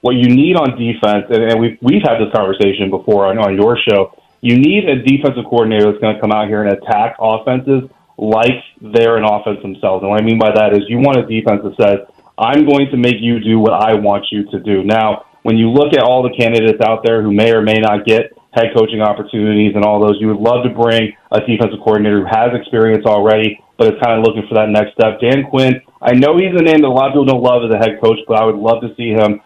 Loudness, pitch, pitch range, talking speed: -12 LUFS, 110 Hz, 105-120 Hz, 255 wpm